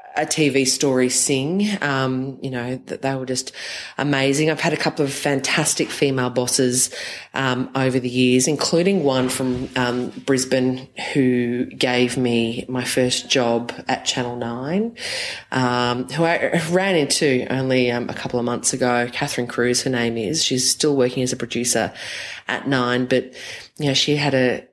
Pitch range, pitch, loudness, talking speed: 125-140 Hz, 130 Hz, -20 LUFS, 165 wpm